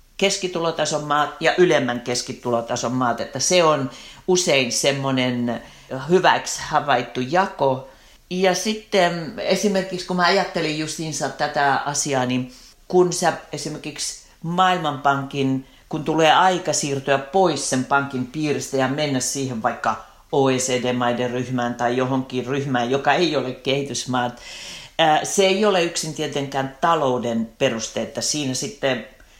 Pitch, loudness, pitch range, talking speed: 140 Hz, -21 LUFS, 125-165 Hz, 120 wpm